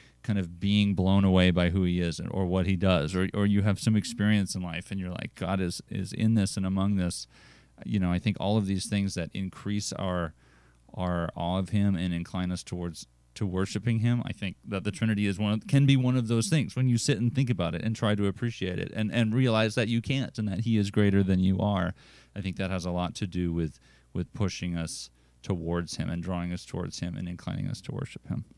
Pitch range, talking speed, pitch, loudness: 90-105 Hz, 250 wpm, 95 Hz, -28 LUFS